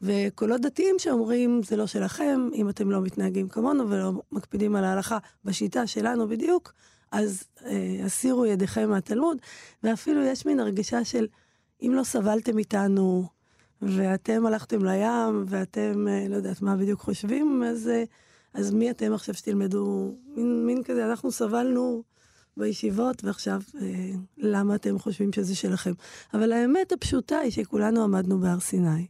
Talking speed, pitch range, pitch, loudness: 145 wpm, 195-240 Hz, 215 Hz, -26 LUFS